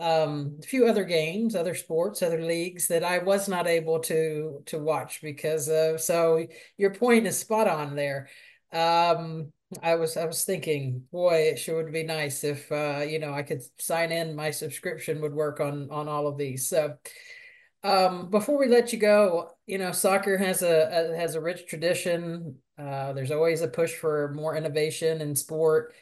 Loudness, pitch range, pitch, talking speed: -26 LUFS, 155-180 Hz, 165 Hz, 190 wpm